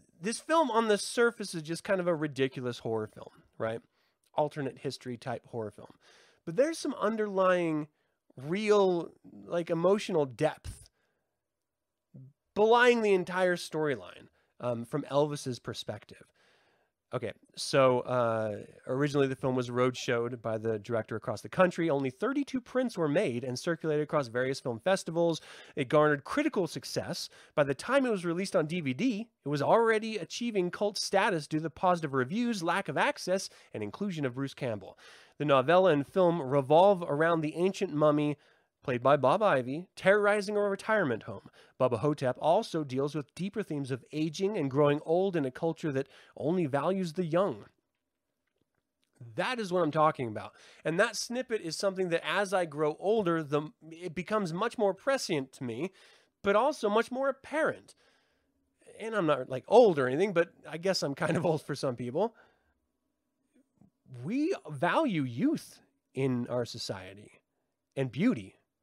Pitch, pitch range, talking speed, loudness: 165 Hz, 135-200 Hz, 160 wpm, -30 LUFS